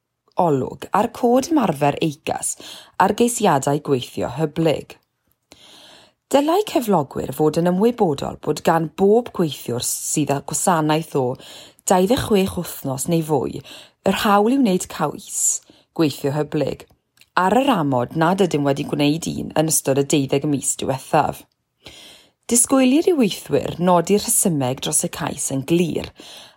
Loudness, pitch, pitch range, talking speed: -19 LUFS, 165 Hz, 145-205 Hz, 130 wpm